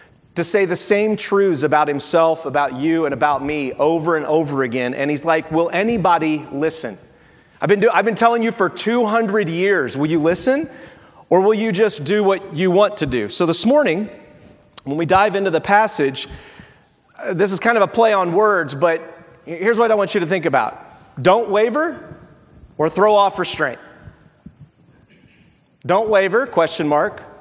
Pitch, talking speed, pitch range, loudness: 180 Hz, 175 wpm, 155-210 Hz, -17 LUFS